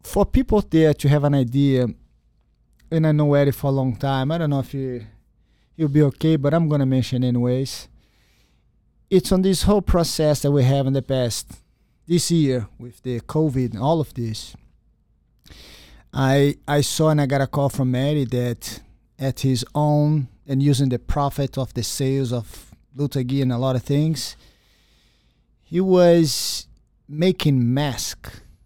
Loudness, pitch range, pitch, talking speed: -20 LUFS, 125-150 Hz, 140 Hz, 170 wpm